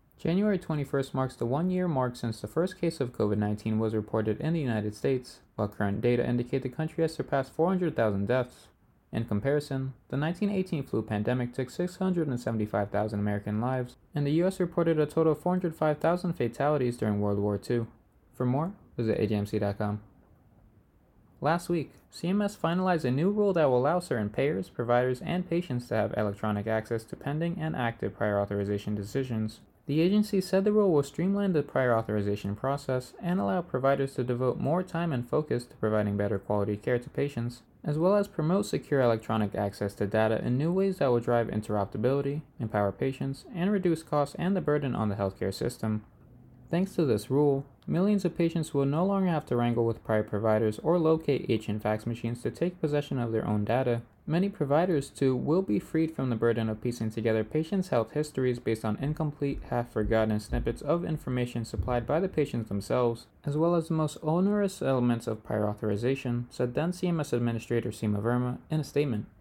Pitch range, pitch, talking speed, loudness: 110-160 Hz, 125 Hz, 180 wpm, -29 LUFS